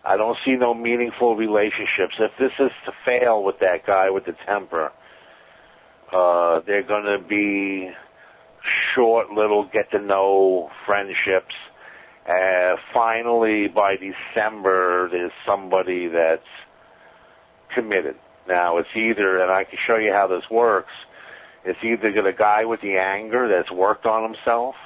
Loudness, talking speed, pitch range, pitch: -20 LUFS, 140 wpm, 95-115 Hz, 100 Hz